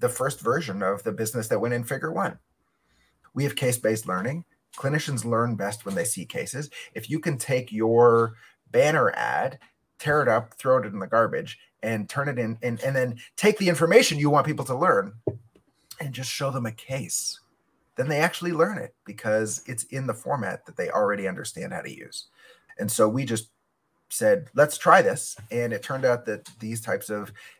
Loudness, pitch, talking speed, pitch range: -25 LUFS, 125 Hz, 200 wpm, 110-145 Hz